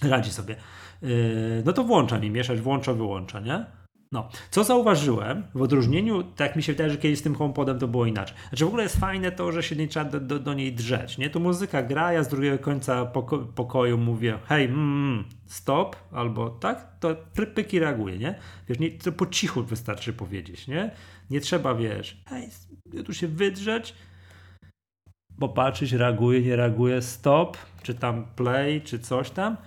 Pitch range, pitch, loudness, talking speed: 115-155 Hz, 130 Hz, -26 LUFS, 180 wpm